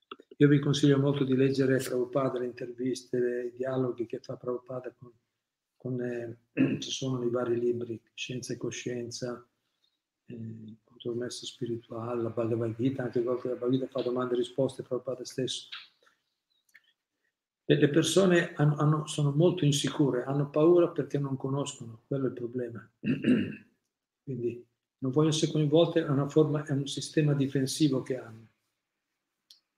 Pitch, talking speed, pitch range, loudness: 125 Hz, 135 wpm, 120-145 Hz, -29 LUFS